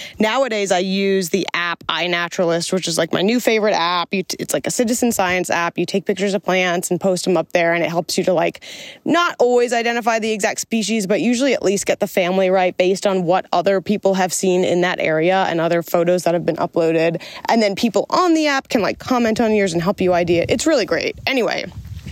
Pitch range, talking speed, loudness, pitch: 175-225 Hz, 230 wpm, -18 LUFS, 190 Hz